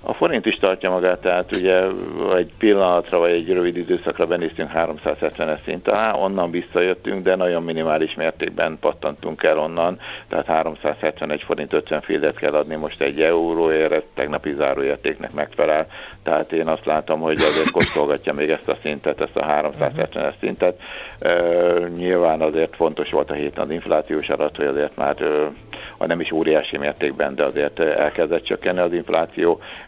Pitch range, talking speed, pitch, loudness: 80-90 Hz, 160 wpm, 85 Hz, -20 LUFS